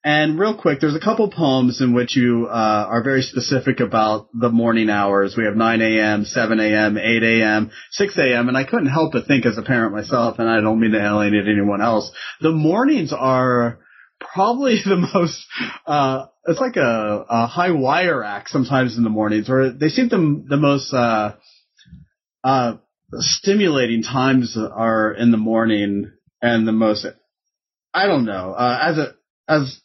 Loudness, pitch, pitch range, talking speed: -18 LUFS, 120 Hz, 110-140 Hz, 170 wpm